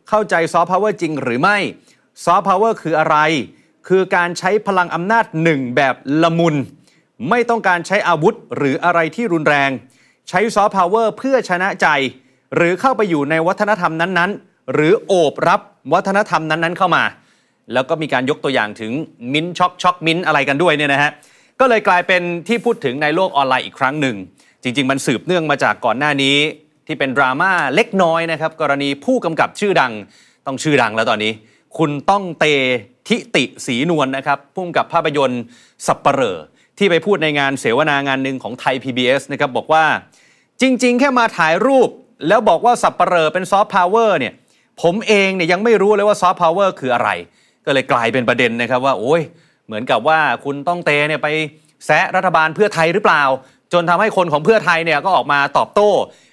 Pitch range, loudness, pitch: 140-190 Hz, -16 LUFS, 165 Hz